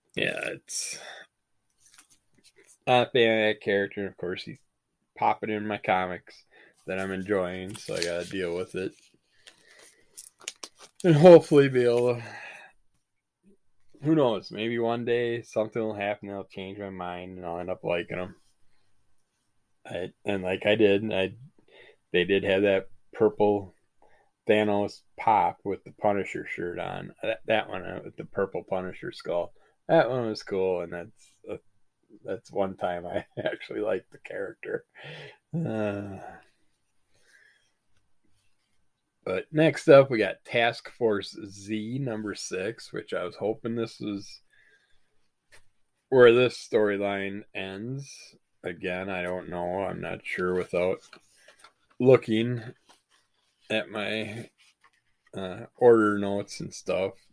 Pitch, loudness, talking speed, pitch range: 105 Hz, -27 LUFS, 135 wpm, 95-120 Hz